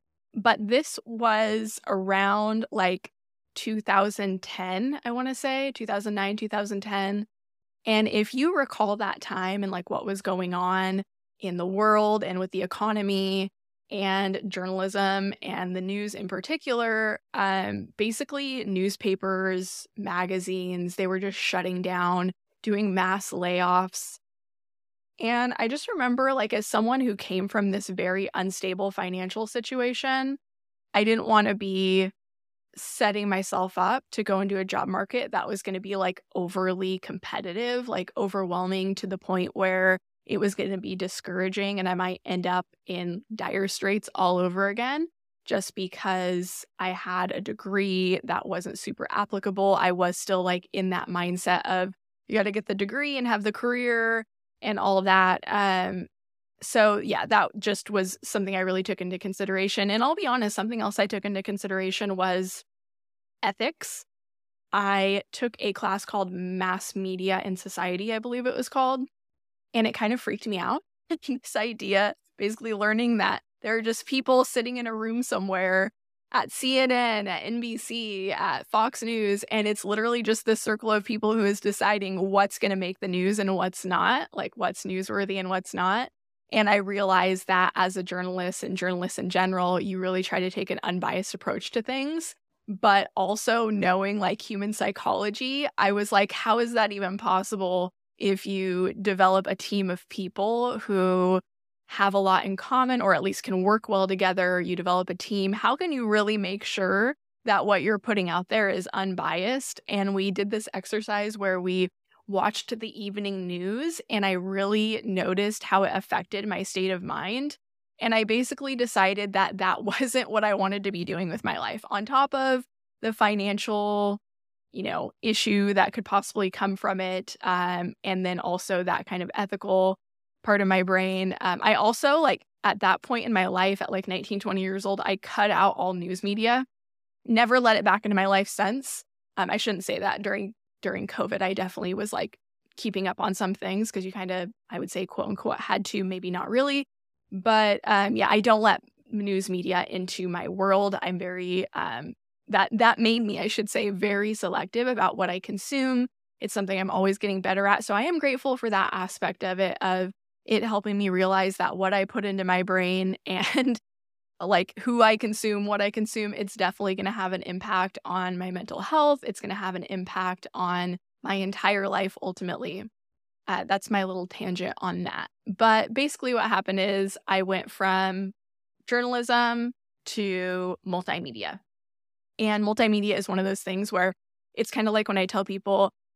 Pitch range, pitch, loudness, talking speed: 185-215 Hz, 195 Hz, -26 LUFS, 180 wpm